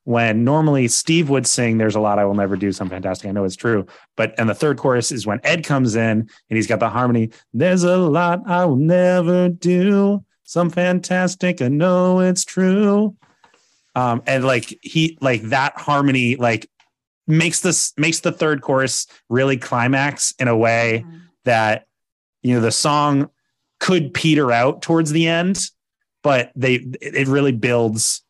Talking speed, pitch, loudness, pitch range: 170 wpm, 135 Hz, -18 LUFS, 115-170 Hz